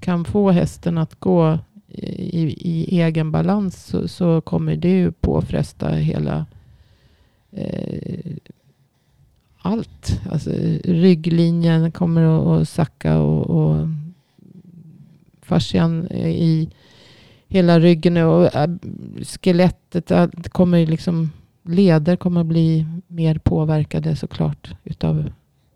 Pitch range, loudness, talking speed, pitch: 160-175 Hz, -19 LUFS, 105 wpm, 165 Hz